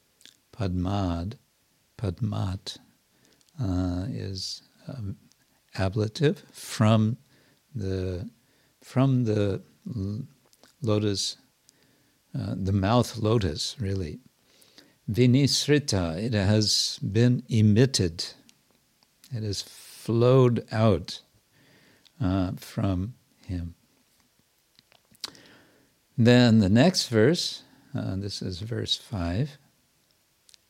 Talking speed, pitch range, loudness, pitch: 75 wpm, 95-130 Hz, -26 LUFS, 110 Hz